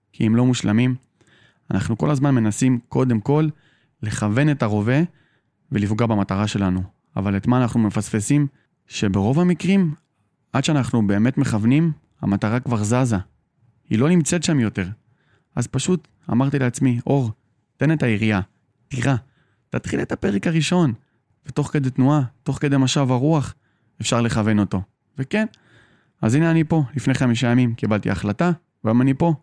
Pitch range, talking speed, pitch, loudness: 110-145 Hz, 145 wpm, 125 Hz, -20 LUFS